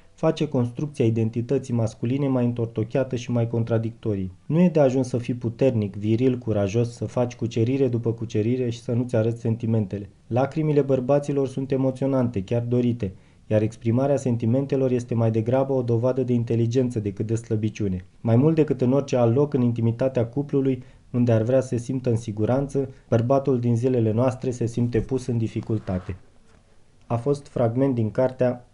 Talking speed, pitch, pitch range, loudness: 165 wpm, 120 Hz, 115-130 Hz, -24 LUFS